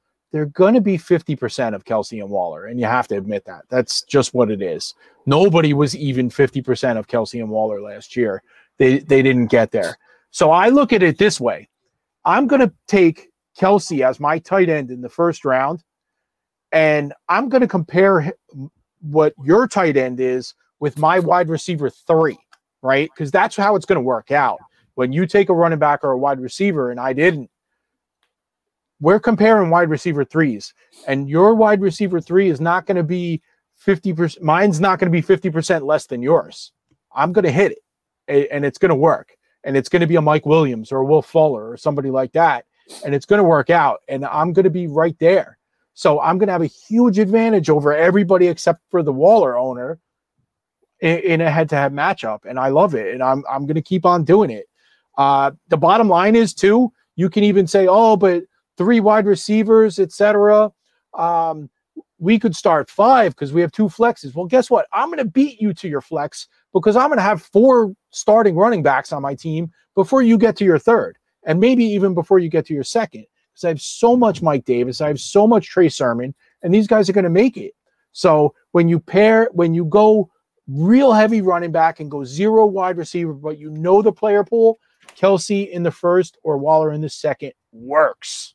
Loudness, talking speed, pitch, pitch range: -16 LUFS, 205 wpm, 175 Hz, 150-205 Hz